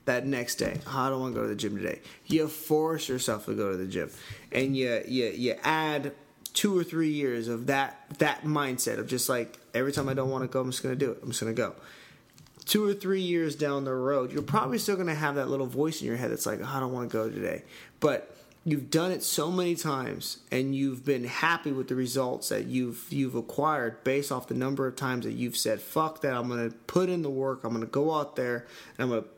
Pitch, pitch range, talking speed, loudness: 135 Hz, 125-155 Hz, 250 wpm, -30 LUFS